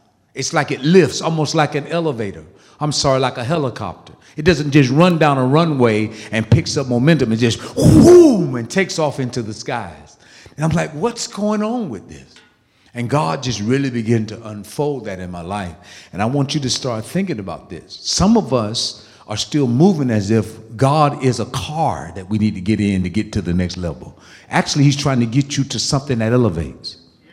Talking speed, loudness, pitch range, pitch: 210 wpm, -17 LUFS, 110-150 Hz, 130 Hz